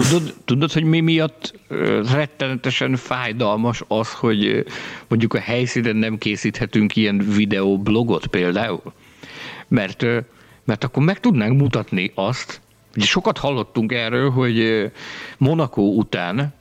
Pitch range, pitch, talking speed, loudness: 110-135 Hz, 120 Hz, 110 wpm, -19 LUFS